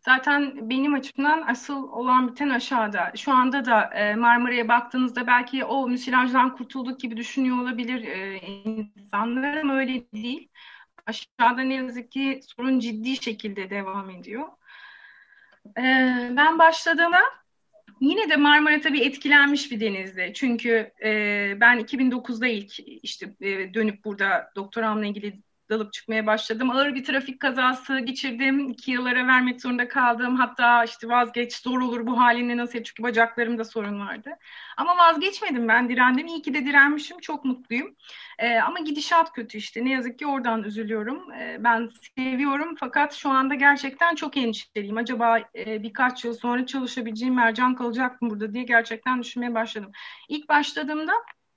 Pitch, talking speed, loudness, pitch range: 250 Hz, 140 wpm, -23 LUFS, 230-275 Hz